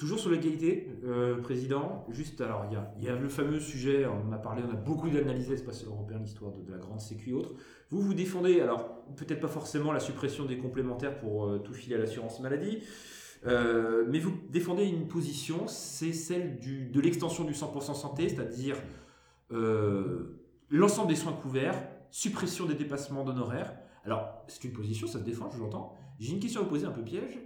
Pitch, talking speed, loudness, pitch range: 135 Hz, 205 wpm, -33 LUFS, 115-160 Hz